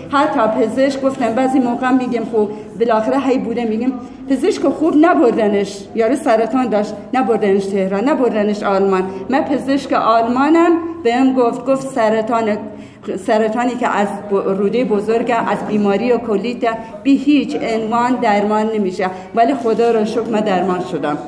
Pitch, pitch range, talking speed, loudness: 230 Hz, 210-260 Hz, 135 wpm, -16 LUFS